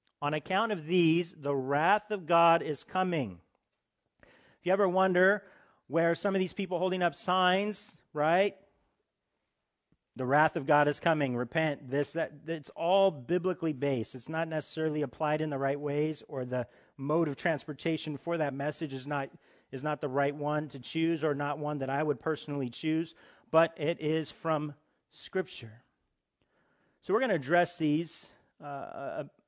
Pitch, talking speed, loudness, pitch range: 155 Hz, 165 wpm, -31 LUFS, 145-170 Hz